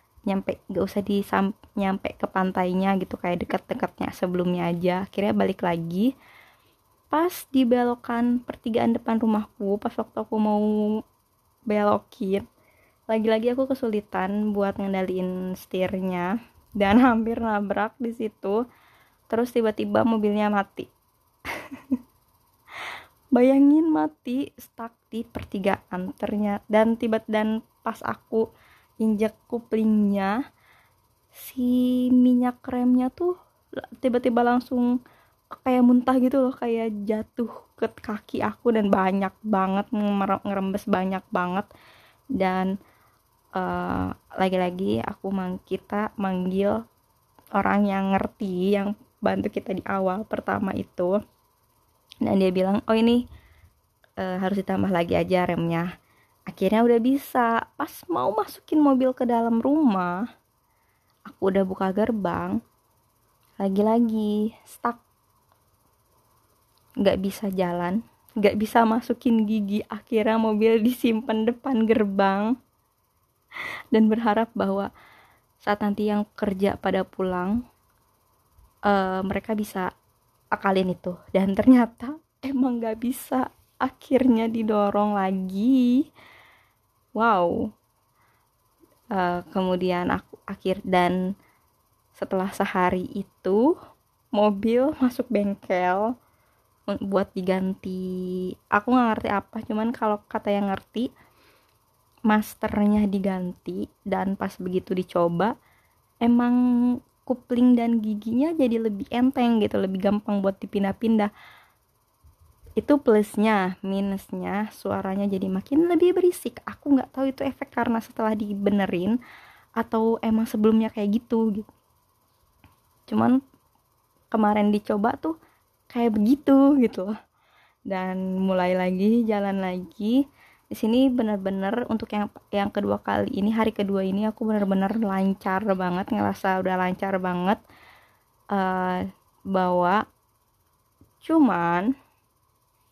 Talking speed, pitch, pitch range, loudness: 105 wpm, 210 Hz, 190-235 Hz, -24 LUFS